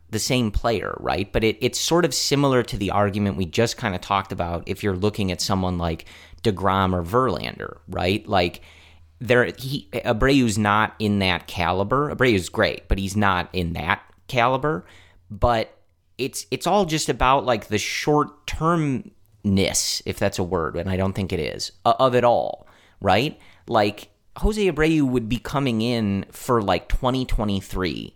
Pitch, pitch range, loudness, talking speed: 105 Hz, 95-125 Hz, -22 LUFS, 170 wpm